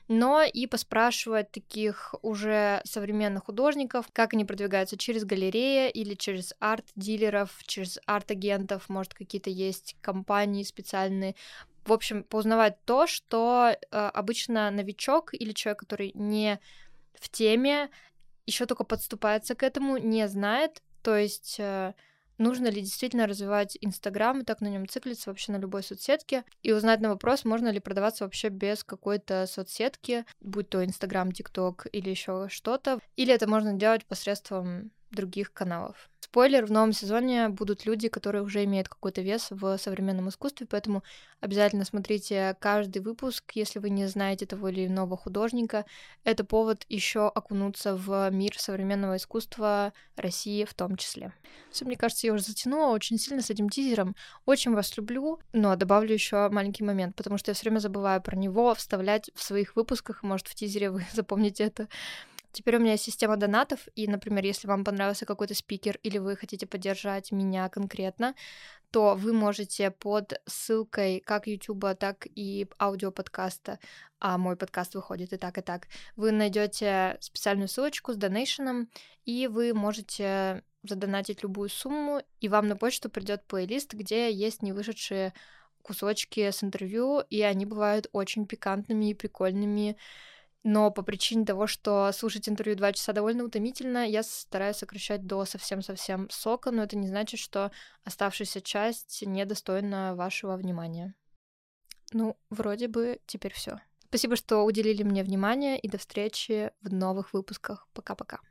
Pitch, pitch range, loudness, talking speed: 210 Hz, 195-225 Hz, -29 LUFS, 150 wpm